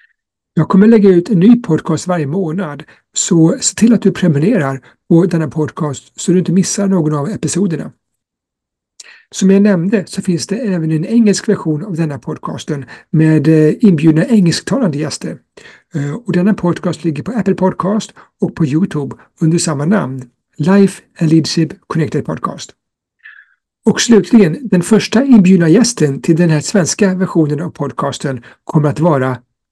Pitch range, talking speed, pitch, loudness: 155-200 Hz, 155 wpm, 175 Hz, -13 LUFS